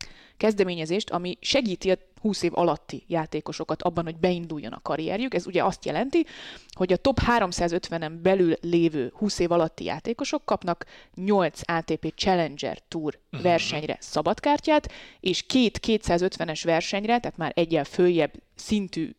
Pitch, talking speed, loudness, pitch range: 175 Hz, 135 wpm, -26 LUFS, 165-205 Hz